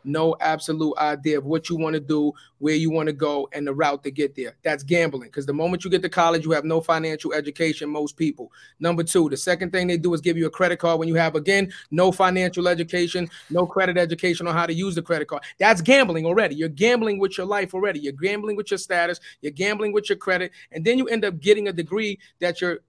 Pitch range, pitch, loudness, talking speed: 155-185 Hz, 170 Hz, -22 LUFS, 250 wpm